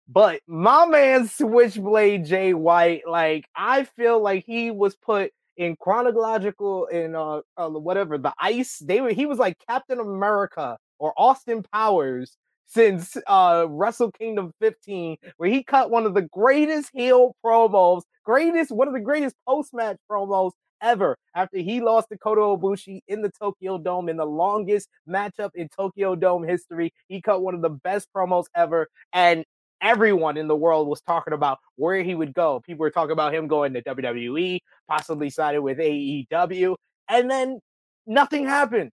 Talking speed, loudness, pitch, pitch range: 165 wpm, -22 LUFS, 195 Hz, 170-230 Hz